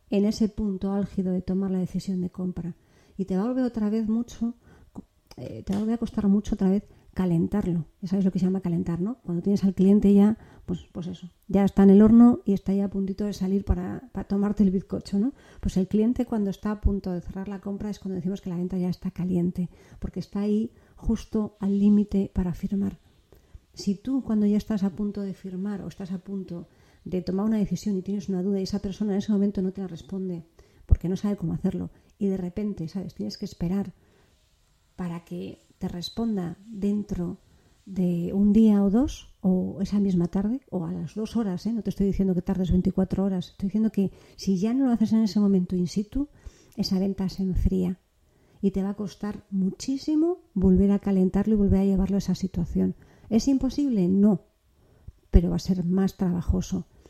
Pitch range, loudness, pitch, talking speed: 185-205 Hz, -26 LUFS, 195 Hz, 215 wpm